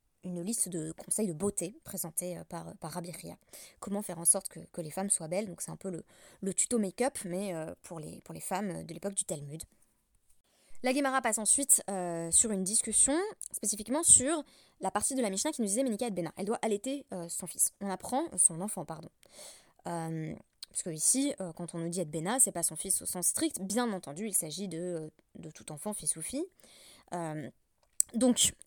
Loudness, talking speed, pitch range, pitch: -30 LUFS, 215 wpm, 170-225 Hz, 190 Hz